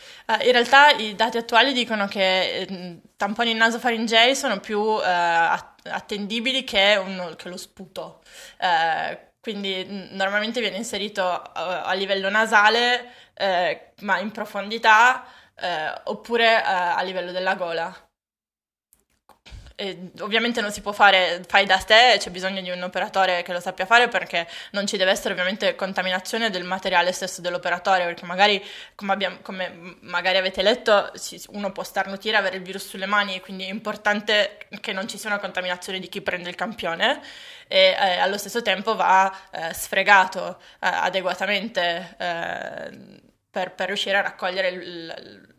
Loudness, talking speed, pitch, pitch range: -21 LUFS, 155 wpm, 195 Hz, 185-220 Hz